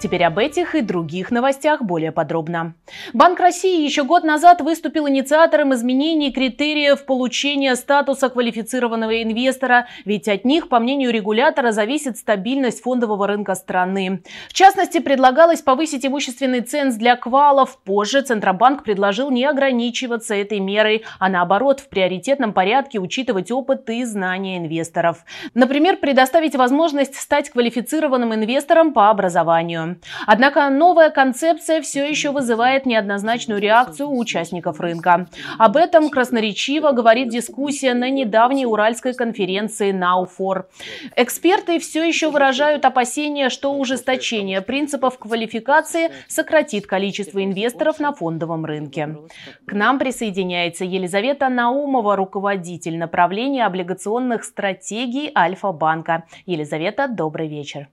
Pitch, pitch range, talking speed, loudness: 245 Hz, 195-280 Hz, 120 wpm, -18 LUFS